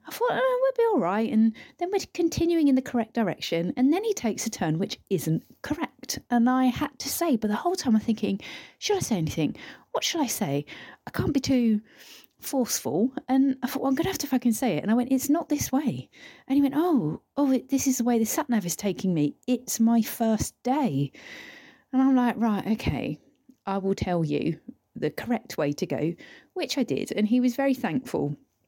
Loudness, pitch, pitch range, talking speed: -26 LUFS, 250 Hz, 215-280 Hz, 225 wpm